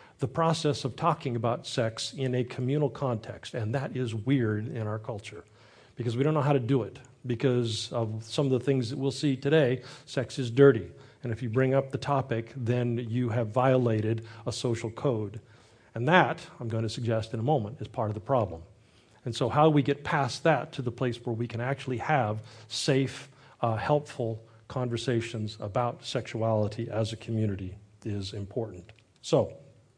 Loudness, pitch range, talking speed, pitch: -29 LUFS, 110-135 Hz, 185 wpm, 120 Hz